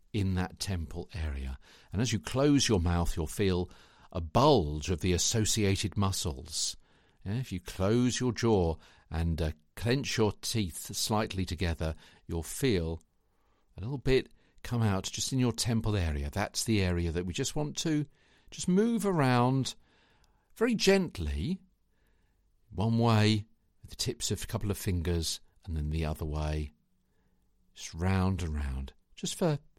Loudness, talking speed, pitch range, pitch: -31 LUFS, 155 wpm, 85-115 Hz, 95 Hz